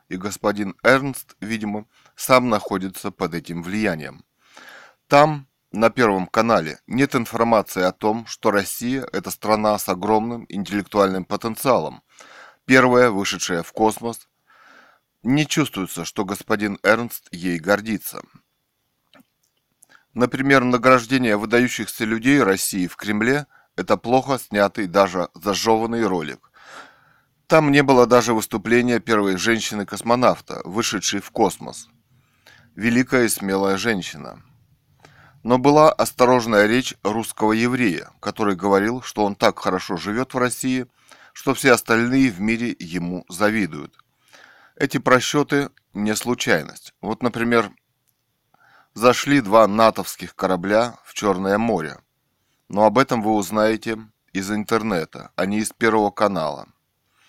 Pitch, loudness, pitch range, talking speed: 110 Hz, -20 LUFS, 100-125 Hz, 115 wpm